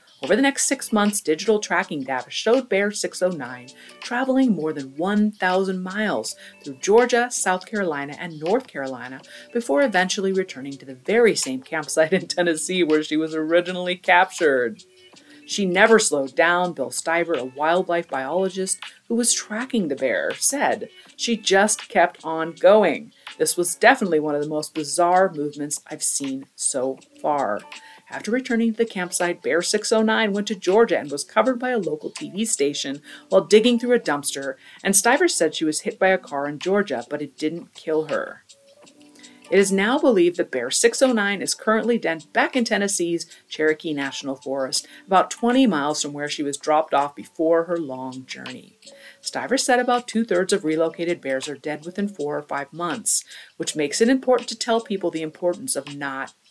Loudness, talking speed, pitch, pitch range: -21 LUFS, 175 wpm, 180 Hz, 155-230 Hz